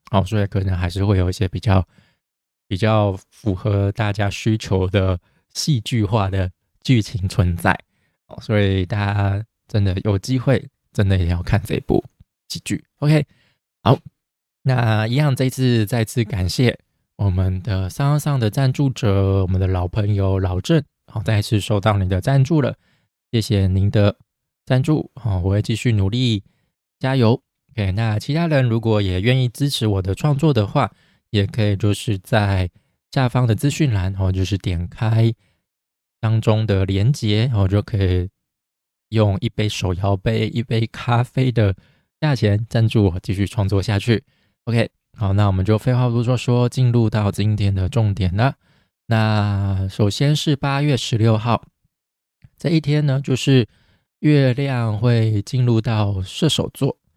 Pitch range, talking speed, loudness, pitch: 95-125 Hz, 235 characters per minute, -19 LUFS, 110 Hz